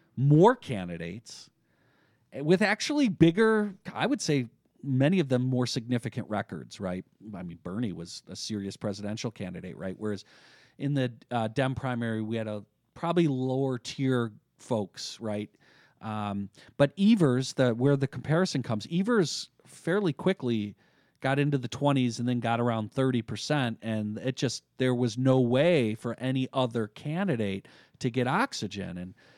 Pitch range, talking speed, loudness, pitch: 110-145 Hz, 150 wpm, -28 LUFS, 125 Hz